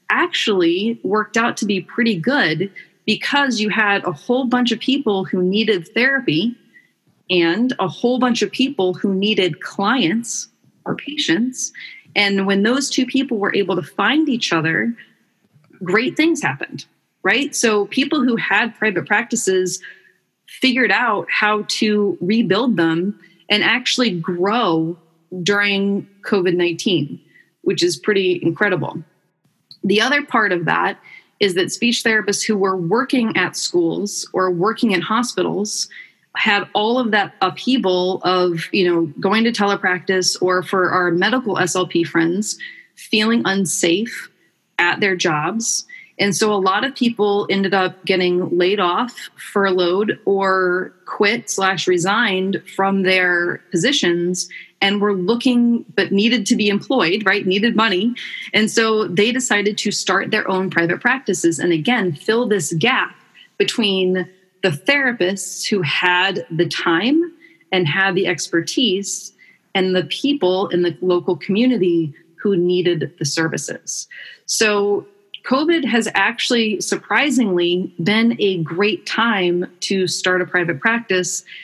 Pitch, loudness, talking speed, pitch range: 200 Hz, -18 LUFS, 135 wpm, 180-230 Hz